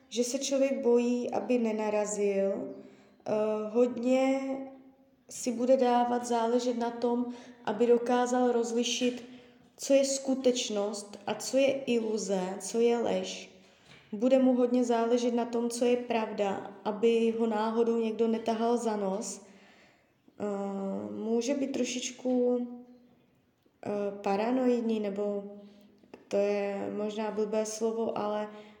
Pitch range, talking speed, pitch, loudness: 210-245 Hz, 110 wpm, 235 Hz, -30 LUFS